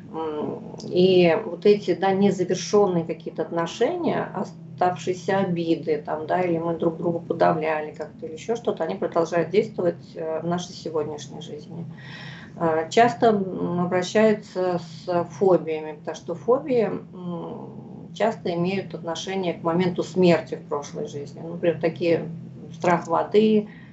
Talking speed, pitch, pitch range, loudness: 120 wpm, 170 Hz, 165-190 Hz, -24 LUFS